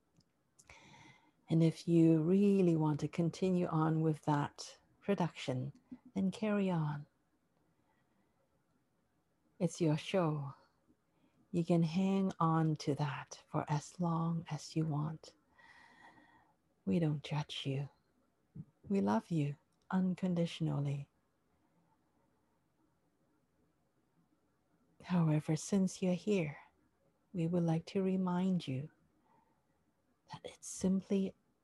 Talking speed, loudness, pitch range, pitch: 95 wpm, -36 LUFS, 150-190 Hz, 165 Hz